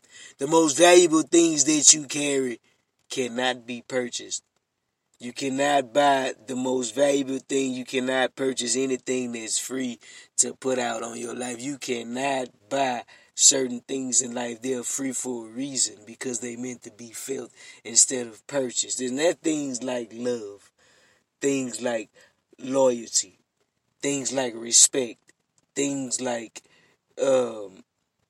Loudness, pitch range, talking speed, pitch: -23 LUFS, 120-140 Hz, 140 wpm, 130 Hz